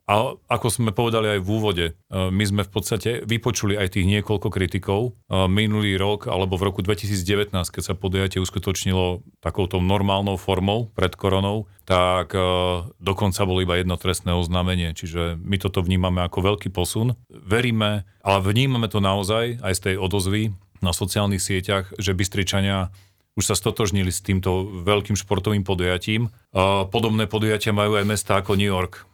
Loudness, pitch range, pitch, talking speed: -22 LUFS, 95-105 Hz, 100 Hz, 155 wpm